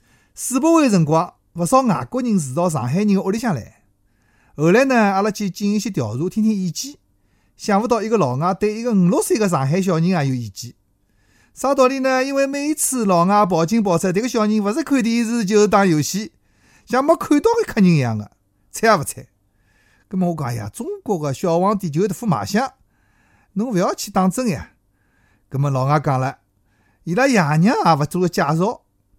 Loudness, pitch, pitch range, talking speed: -18 LUFS, 185 Hz, 130-220 Hz, 300 characters per minute